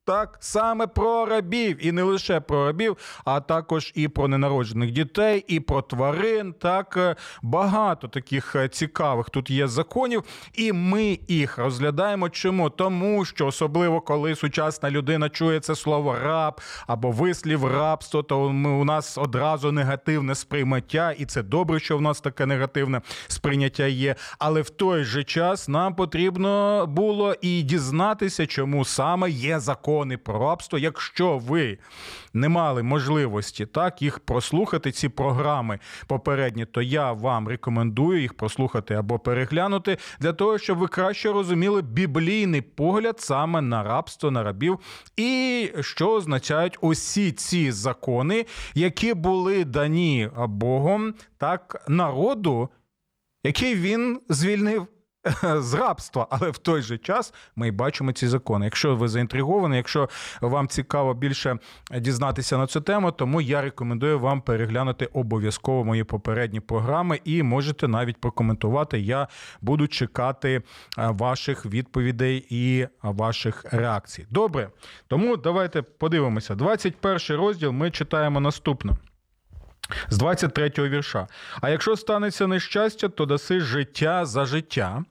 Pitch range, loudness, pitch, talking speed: 130-175 Hz, -24 LUFS, 150 Hz, 130 wpm